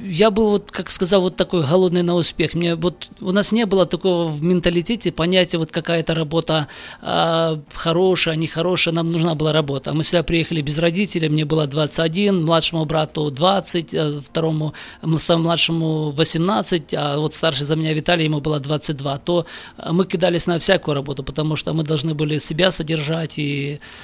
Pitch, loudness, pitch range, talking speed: 165 Hz, -19 LUFS, 155-180 Hz, 170 wpm